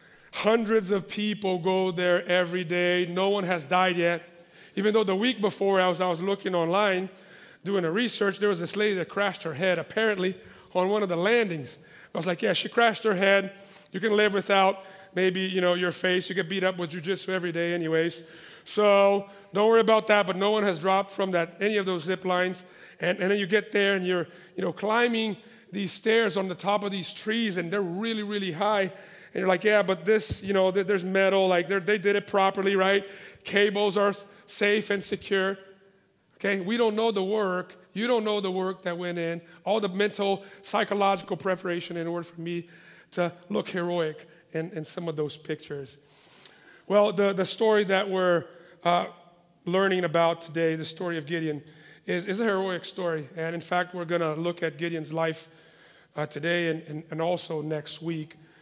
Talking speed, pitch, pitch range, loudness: 200 wpm, 190 Hz, 175-200 Hz, -26 LUFS